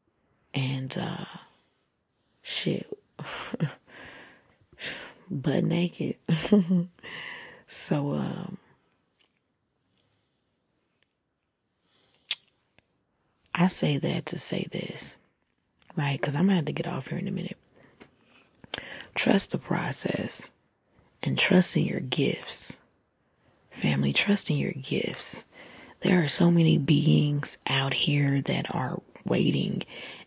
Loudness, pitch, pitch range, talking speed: -27 LUFS, 170 Hz, 145-185 Hz, 95 wpm